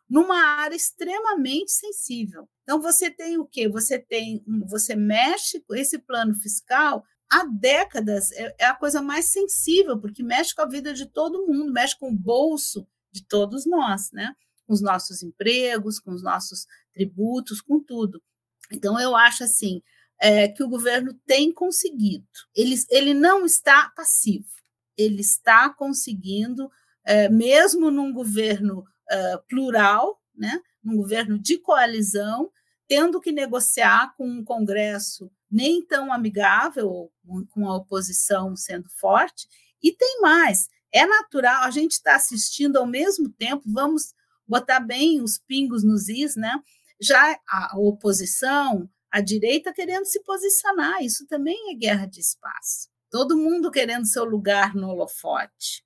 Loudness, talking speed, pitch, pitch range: -21 LUFS, 145 wpm, 245 Hz, 210-300 Hz